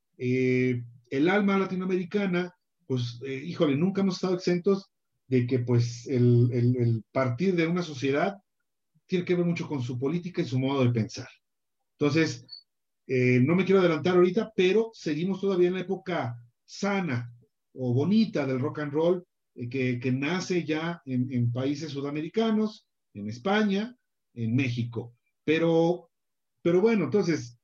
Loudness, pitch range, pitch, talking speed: -27 LUFS, 125-180 Hz, 150 Hz, 150 wpm